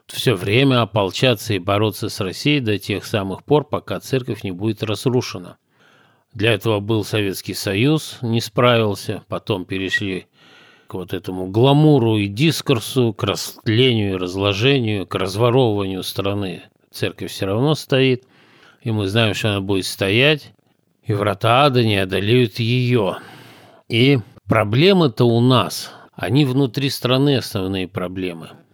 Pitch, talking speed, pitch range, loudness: 110 Hz, 135 wpm, 100-130 Hz, -18 LUFS